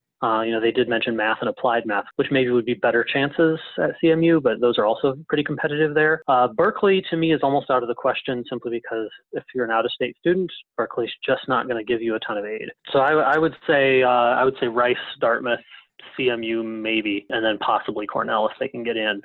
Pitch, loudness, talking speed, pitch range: 125 Hz, -21 LUFS, 235 wpm, 115-150 Hz